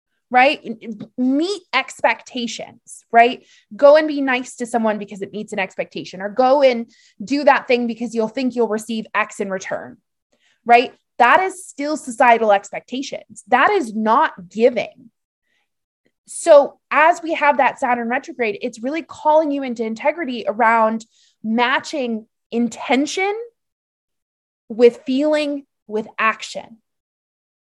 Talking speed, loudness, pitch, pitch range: 130 wpm, -18 LUFS, 245 Hz, 225-285 Hz